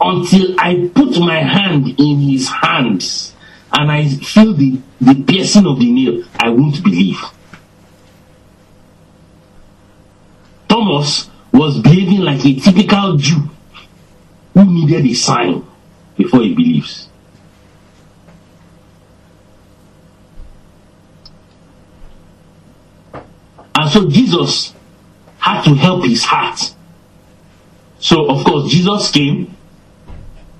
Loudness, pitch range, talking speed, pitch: -12 LUFS, 130-190 Hz, 90 wpm, 155 Hz